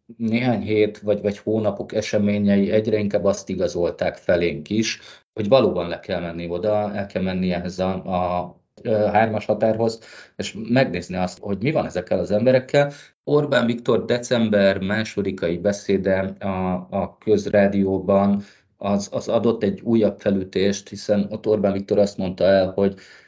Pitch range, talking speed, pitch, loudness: 95-110 Hz, 150 wpm, 100 Hz, -21 LUFS